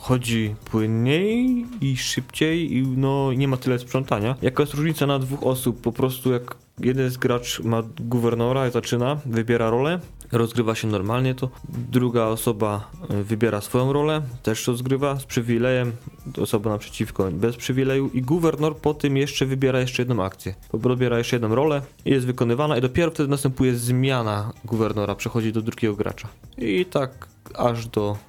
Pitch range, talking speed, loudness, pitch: 115-135 Hz, 160 wpm, -23 LUFS, 125 Hz